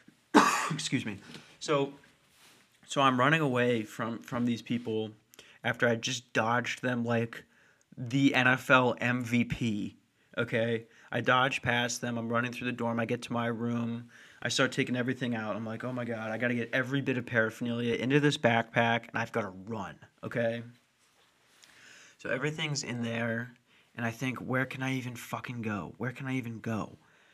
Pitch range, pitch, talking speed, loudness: 115-130 Hz, 120 Hz, 170 wpm, -31 LUFS